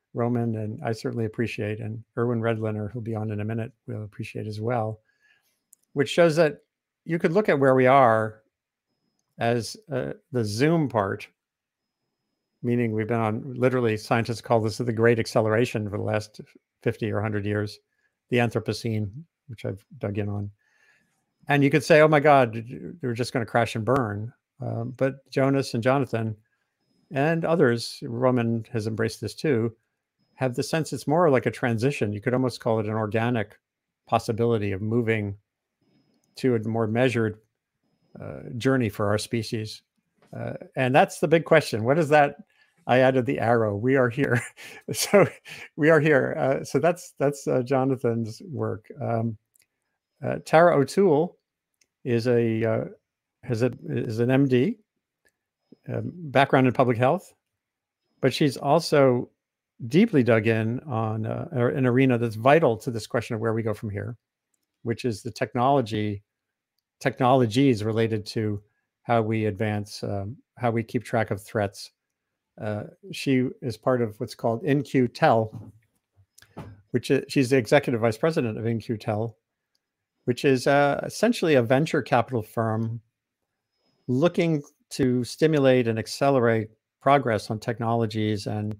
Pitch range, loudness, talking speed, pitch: 110-135 Hz, -24 LUFS, 155 wpm, 120 Hz